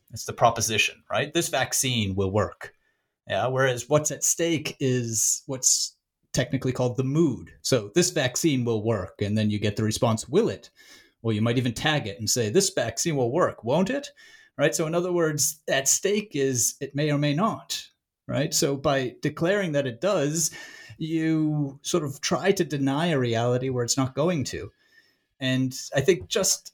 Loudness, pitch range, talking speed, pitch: -25 LUFS, 120-165 Hz, 185 wpm, 140 Hz